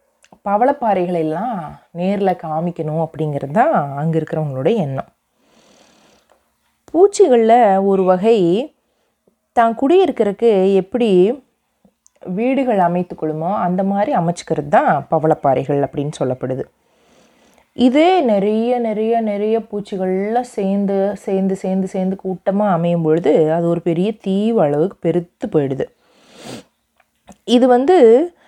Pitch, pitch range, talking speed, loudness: 195 Hz, 170-230 Hz, 95 wpm, -16 LUFS